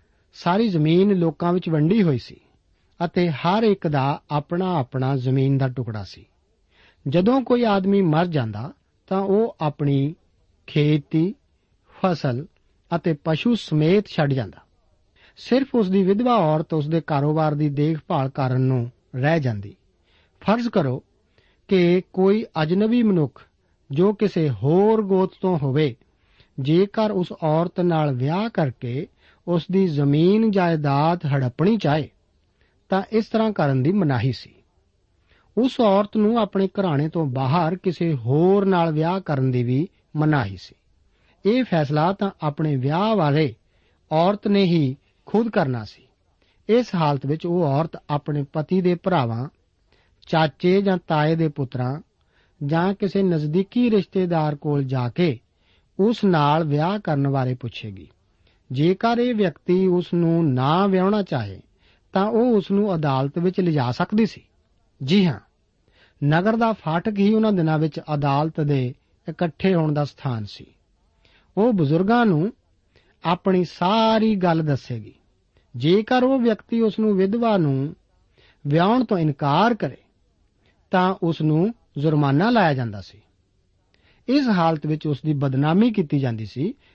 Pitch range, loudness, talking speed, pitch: 130-190 Hz, -21 LUFS, 140 wpm, 155 Hz